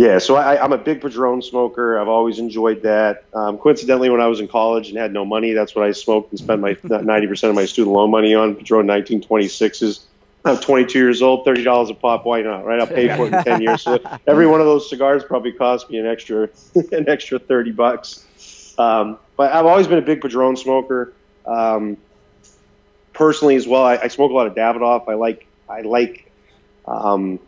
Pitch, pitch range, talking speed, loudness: 115 Hz, 110-130 Hz, 210 wpm, -16 LUFS